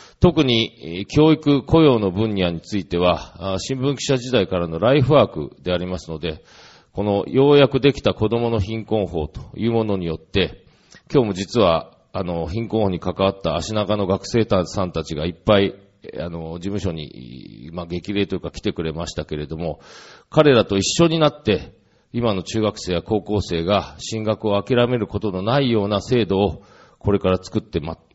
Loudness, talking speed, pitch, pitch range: -20 LUFS, 340 characters per minute, 100 Hz, 90-115 Hz